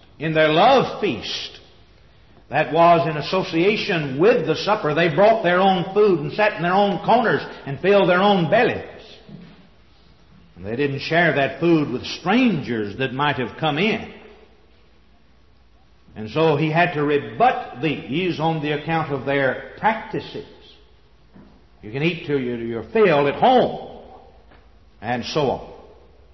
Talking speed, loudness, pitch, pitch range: 145 wpm, -19 LUFS, 150 Hz, 115-175 Hz